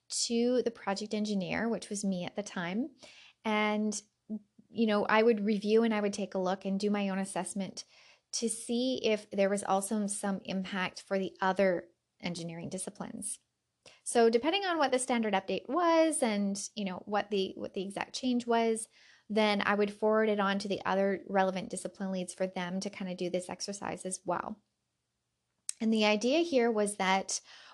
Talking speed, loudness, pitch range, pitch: 185 wpm, -32 LUFS, 190-225 Hz, 205 Hz